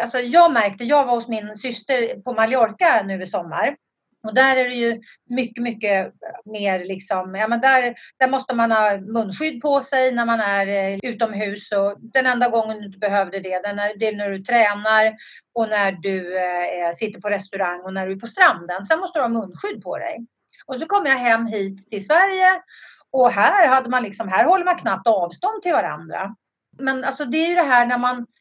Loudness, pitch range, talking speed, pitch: -20 LUFS, 200-260 Hz, 205 wpm, 230 Hz